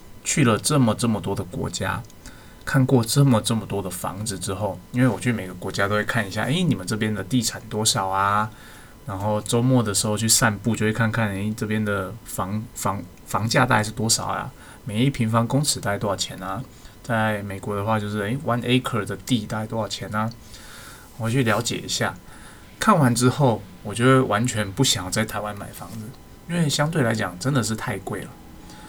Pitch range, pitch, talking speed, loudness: 100-125 Hz, 110 Hz, 300 characters per minute, -23 LUFS